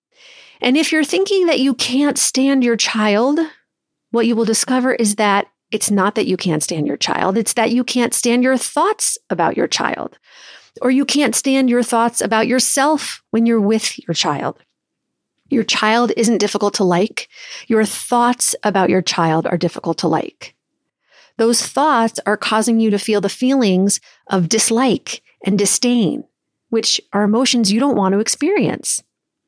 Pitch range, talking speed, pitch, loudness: 205-255 Hz, 170 wpm, 230 Hz, -16 LUFS